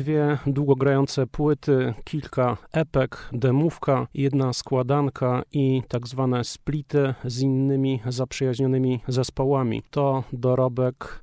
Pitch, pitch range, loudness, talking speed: 135 Hz, 125-140 Hz, -24 LUFS, 95 wpm